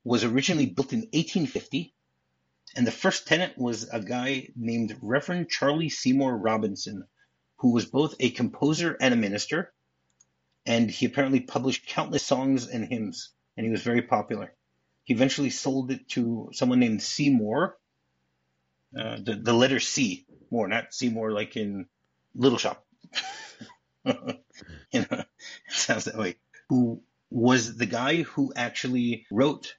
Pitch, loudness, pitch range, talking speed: 120 Hz, -27 LUFS, 105-135 Hz, 145 wpm